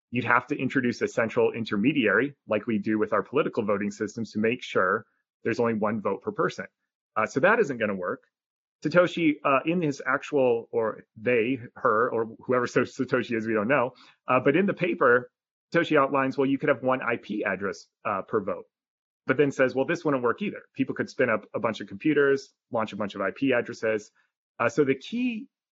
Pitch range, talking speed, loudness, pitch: 115-155 Hz, 210 wpm, -26 LUFS, 130 Hz